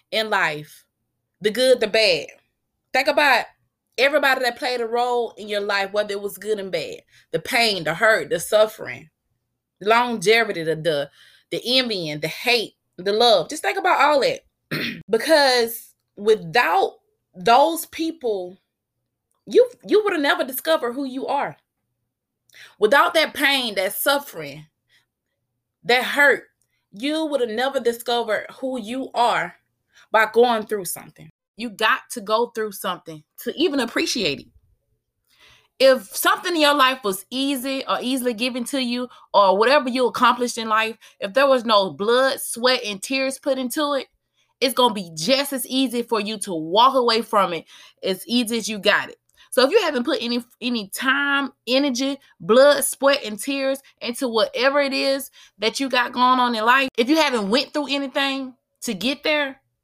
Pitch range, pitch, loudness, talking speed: 210-275 Hz, 245 Hz, -20 LUFS, 165 wpm